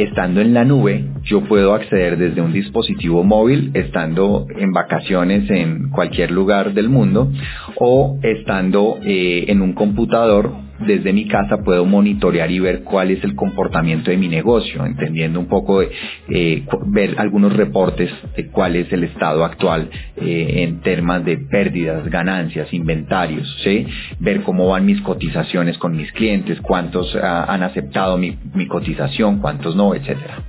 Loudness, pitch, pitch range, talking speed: -16 LUFS, 90 Hz, 85-100 Hz, 155 wpm